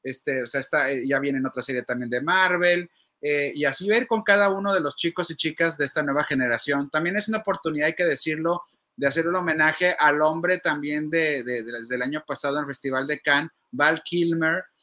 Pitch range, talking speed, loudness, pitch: 140-175 Hz, 225 wpm, -23 LUFS, 150 Hz